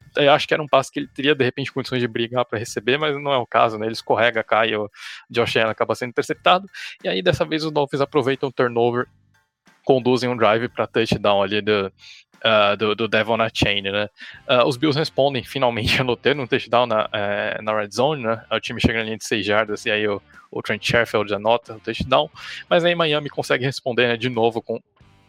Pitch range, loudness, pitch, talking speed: 110-135 Hz, -20 LUFS, 120 Hz, 220 wpm